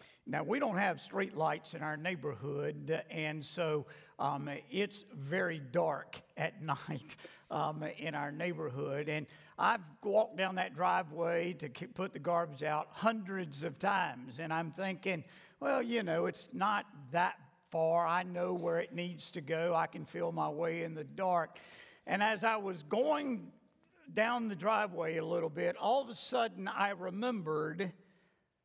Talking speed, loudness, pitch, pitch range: 160 wpm, -36 LUFS, 170 Hz, 155-195 Hz